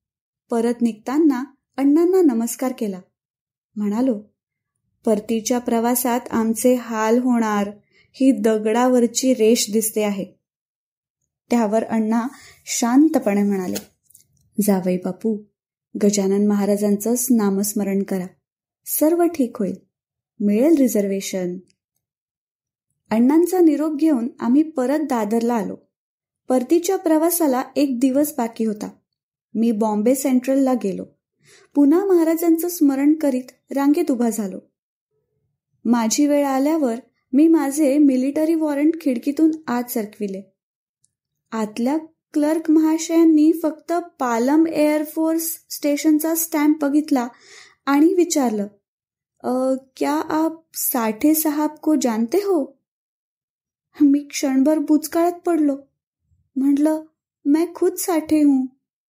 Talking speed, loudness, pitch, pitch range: 90 wpm, -19 LUFS, 265 Hz, 225-310 Hz